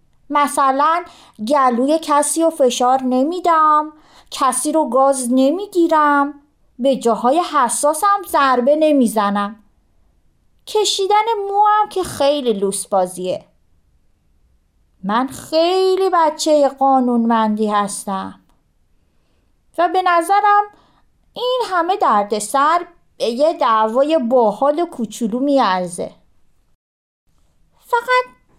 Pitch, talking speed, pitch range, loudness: 275 Hz, 85 wpm, 220-335 Hz, -16 LUFS